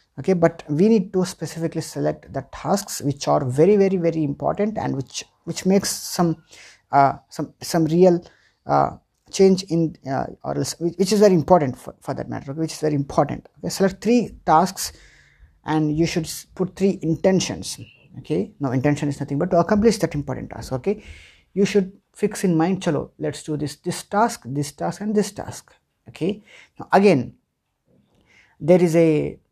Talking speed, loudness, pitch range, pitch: 175 wpm, -21 LUFS, 145-190 Hz, 165 Hz